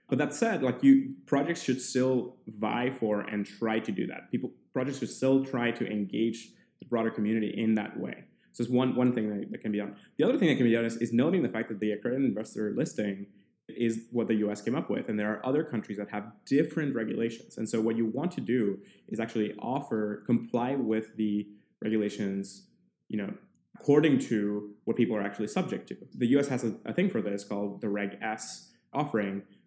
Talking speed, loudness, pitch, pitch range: 215 wpm, -30 LUFS, 110 Hz, 105-125 Hz